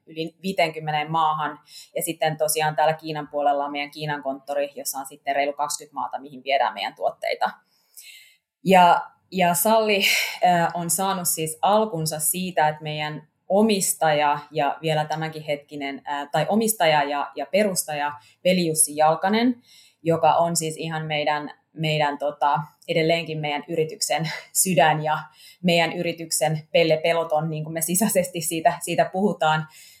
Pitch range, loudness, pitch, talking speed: 150-170 Hz, -23 LUFS, 155 Hz, 140 wpm